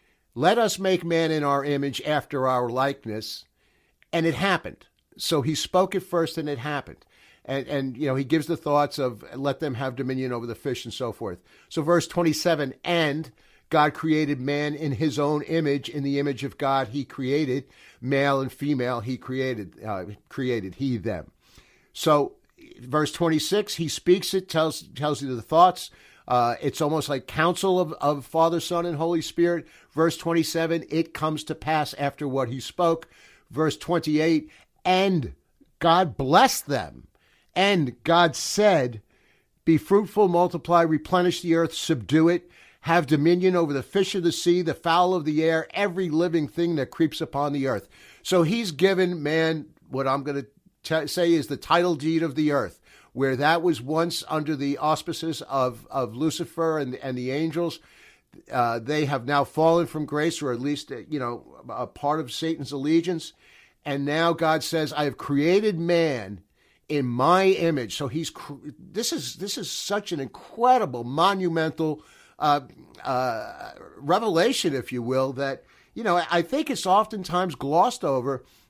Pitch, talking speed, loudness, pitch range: 155 Hz, 170 wpm, -24 LUFS, 140-170 Hz